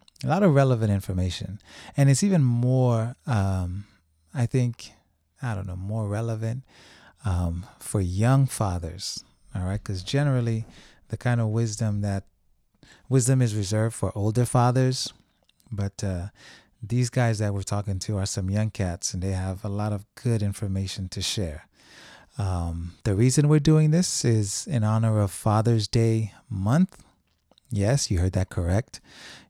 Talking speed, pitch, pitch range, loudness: 155 wpm, 105 Hz, 95-120 Hz, -25 LUFS